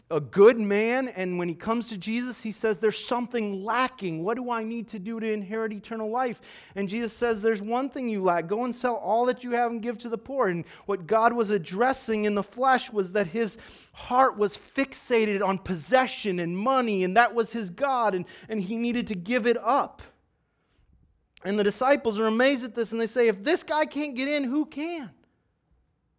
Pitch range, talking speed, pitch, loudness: 205-250 Hz, 215 wpm, 225 Hz, -26 LUFS